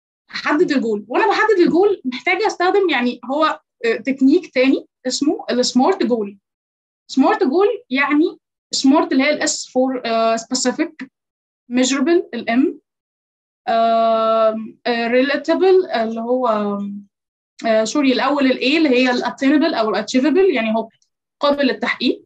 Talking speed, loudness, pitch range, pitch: 125 wpm, -17 LUFS, 230-320 Hz, 260 Hz